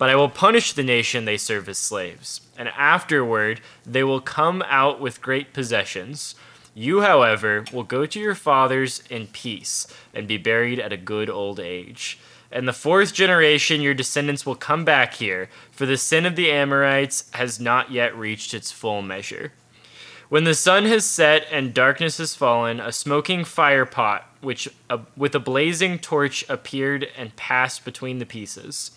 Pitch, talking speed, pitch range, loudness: 135 Hz, 175 wpm, 120-145 Hz, -20 LUFS